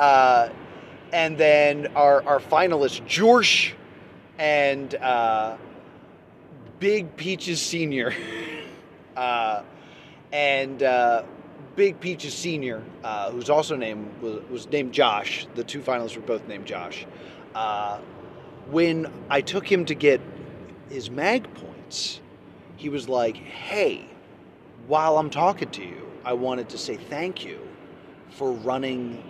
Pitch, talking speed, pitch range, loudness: 145 Hz, 125 wpm, 125-155 Hz, -23 LUFS